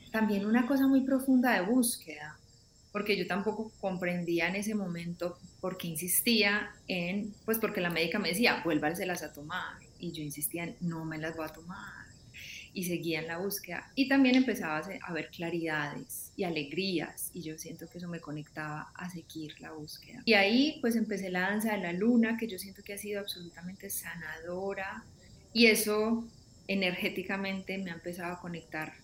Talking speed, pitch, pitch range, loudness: 180 wpm, 185 Hz, 165-210 Hz, -31 LUFS